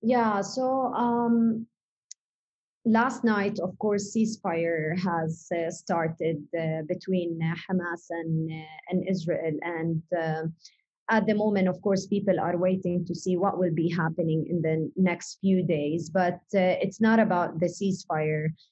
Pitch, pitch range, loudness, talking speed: 180 Hz, 165-200 Hz, -27 LUFS, 150 wpm